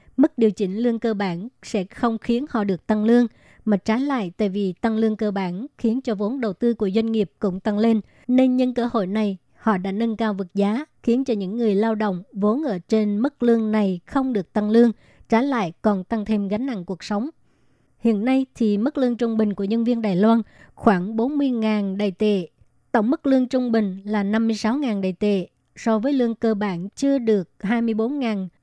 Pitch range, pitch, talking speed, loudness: 205-235 Hz, 220 Hz, 215 wpm, -22 LUFS